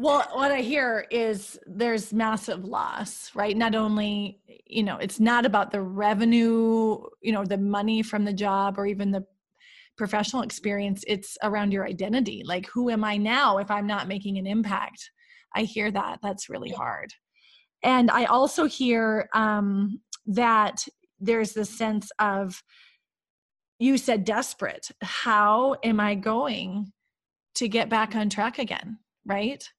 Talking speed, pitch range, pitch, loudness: 150 wpm, 205-235 Hz, 215 Hz, -25 LUFS